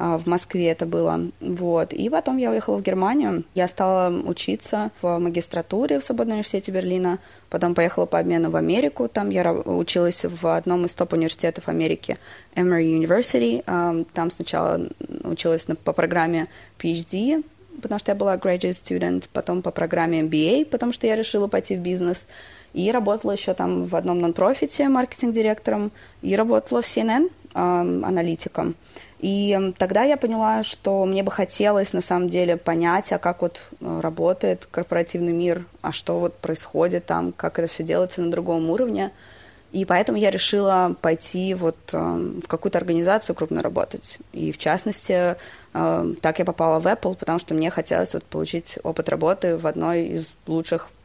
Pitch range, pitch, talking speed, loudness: 160-190 Hz, 175 Hz, 155 wpm, -23 LUFS